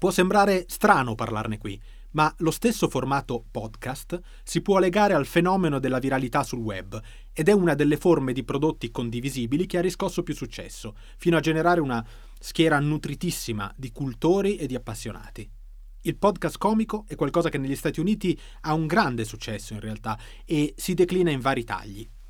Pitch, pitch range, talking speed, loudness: 145 Hz, 115-175 Hz, 170 wpm, -25 LUFS